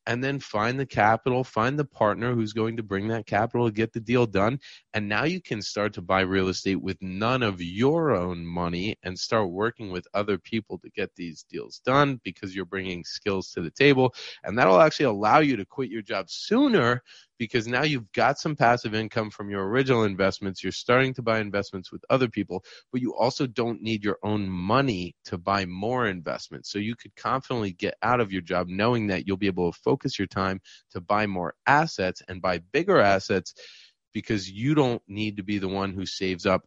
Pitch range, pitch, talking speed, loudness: 95-125 Hz, 105 Hz, 215 wpm, -26 LUFS